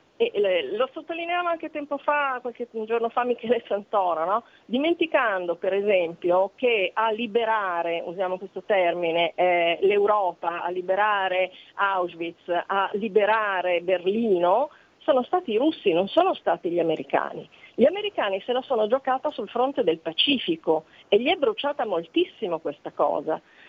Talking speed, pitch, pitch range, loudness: 135 wpm, 215 Hz, 185-280 Hz, -24 LUFS